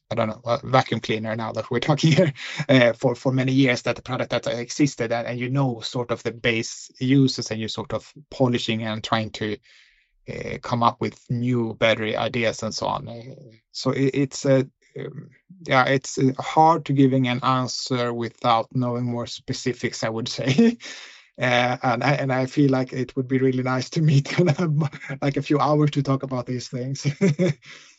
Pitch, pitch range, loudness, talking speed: 130 Hz, 120-140 Hz, -23 LUFS, 190 wpm